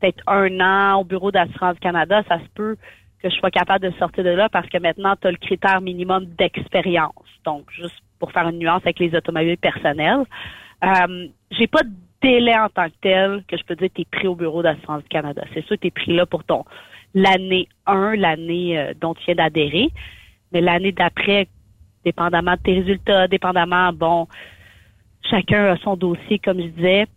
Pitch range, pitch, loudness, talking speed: 170-195 Hz, 180 Hz, -19 LUFS, 205 wpm